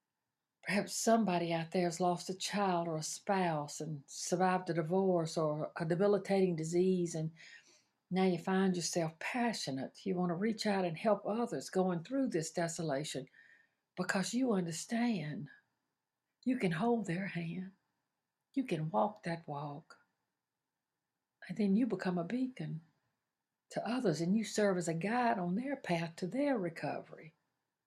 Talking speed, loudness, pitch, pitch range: 150 wpm, -35 LUFS, 180 Hz, 170-205 Hz